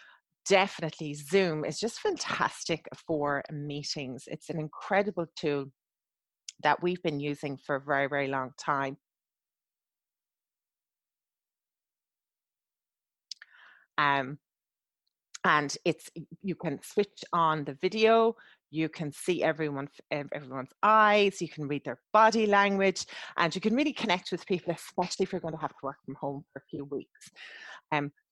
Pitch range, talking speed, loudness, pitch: 145-185 Hz, 135 wpm, -29 LUFS, 155 Hz